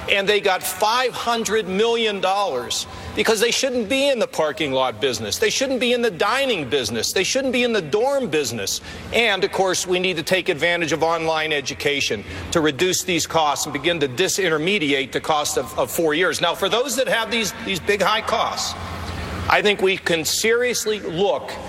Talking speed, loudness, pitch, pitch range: 195 wpm, -20 LUFS, 185 Hz, 155-225 Hz